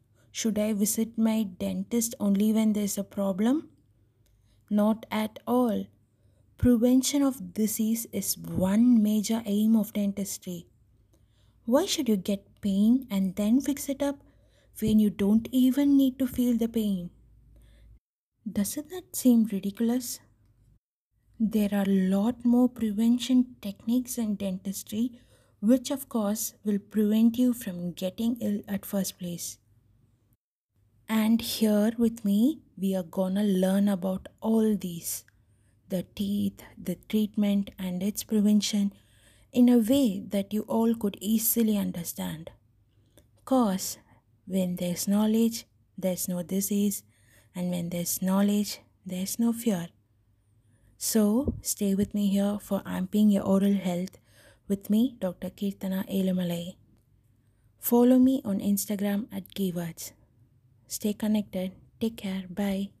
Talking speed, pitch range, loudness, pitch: 125 wpm, 180-225 Hz, -27 LUFS, 200 Hz